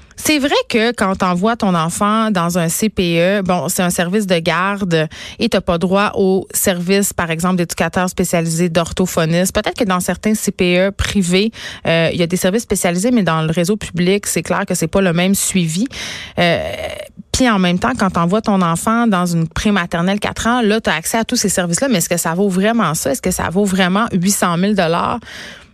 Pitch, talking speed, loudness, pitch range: 190 Hz, 210 wpm, -15 LUFS, 175-210 Hz